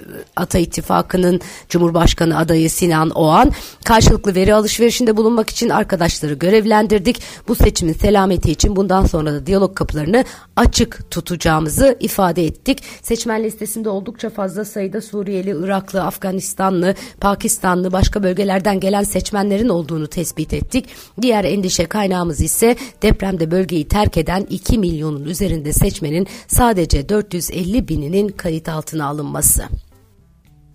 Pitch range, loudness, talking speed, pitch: 165-210 Hz, -16 LUFS, 115 wpm, 190 Hz